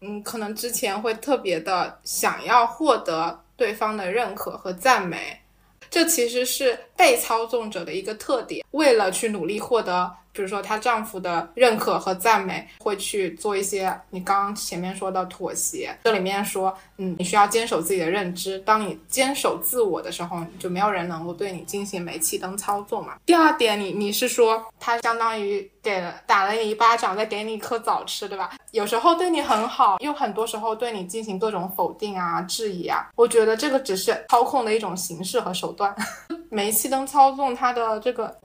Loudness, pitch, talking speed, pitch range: -23 LUFS, 215 Hz, 290 characters per minute, 190-240 Hz